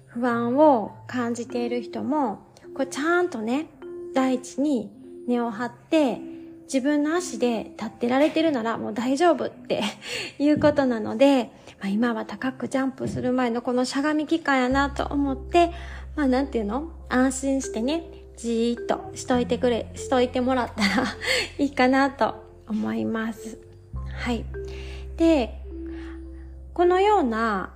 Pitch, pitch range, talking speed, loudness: 250 Hz, 220-285 Hz, 280 characters per minute, -24 LUFS